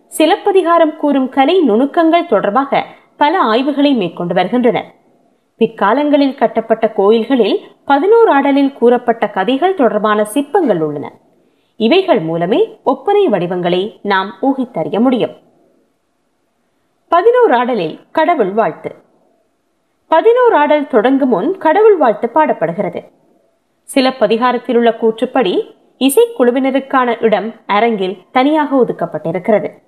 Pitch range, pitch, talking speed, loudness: 215-310 Hz, 255 Hz, 85 wpm, -13 LUFS